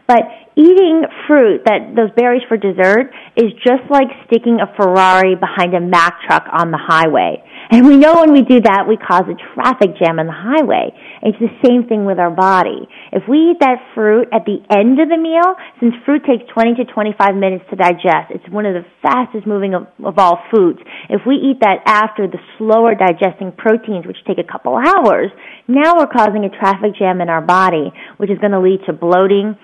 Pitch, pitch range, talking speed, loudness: 215 Hz, 190-250 Hz, 210 wpm, -12 LUFS